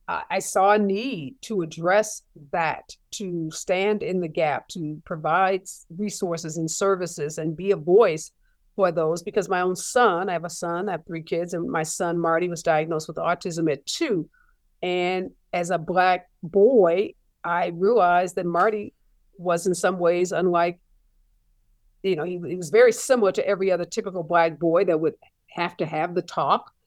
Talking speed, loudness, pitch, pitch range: 175 wpm, -24 LUFS, 180 Hz, 170-195 Hz